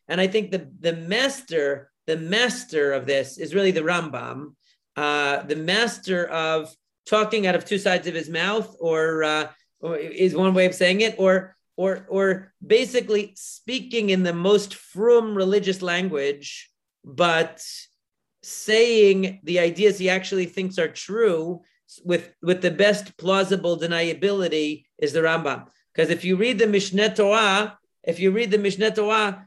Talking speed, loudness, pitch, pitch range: 155 wpm, -22 LUFS, 185 Hz, 165-205 Hz